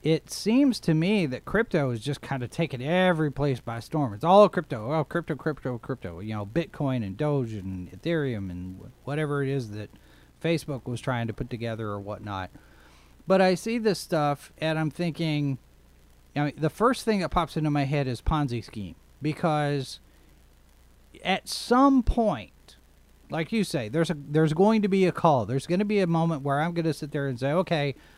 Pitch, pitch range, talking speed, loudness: 145 Hz, 115-170 Hz, 200 wpm, -26 LUFS